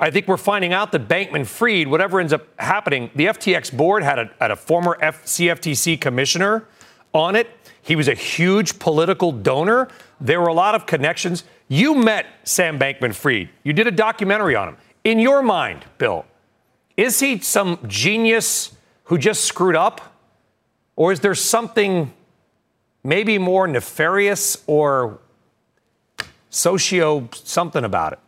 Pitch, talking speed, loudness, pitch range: 180 Hz, 150 wpm, -18 LUFS, 155-215 Hz